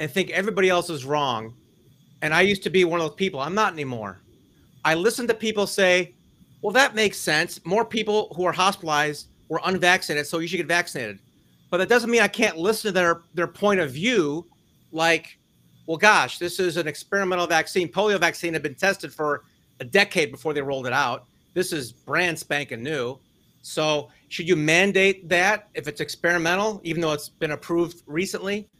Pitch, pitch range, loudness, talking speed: 175 Hz, 155-195 Hz, -23 LUFS, 190 wpm